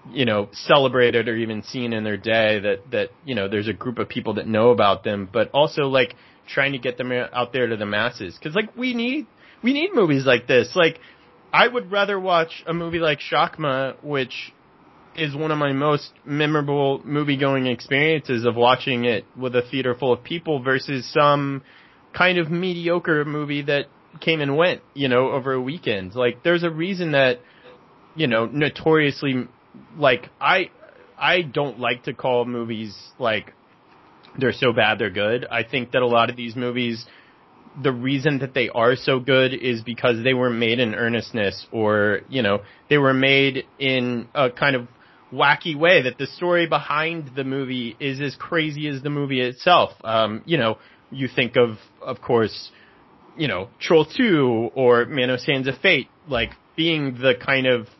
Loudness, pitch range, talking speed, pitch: -21 LUFS, 120-150 Hz, 185 wpm, 135 Hz